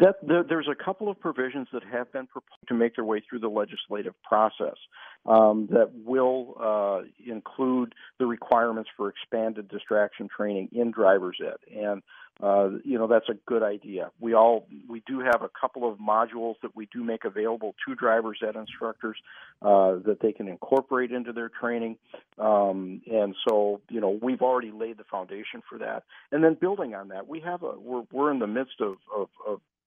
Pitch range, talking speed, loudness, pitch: 105-130 Hz, 190 wpm, -27 LUFS, 115 Hz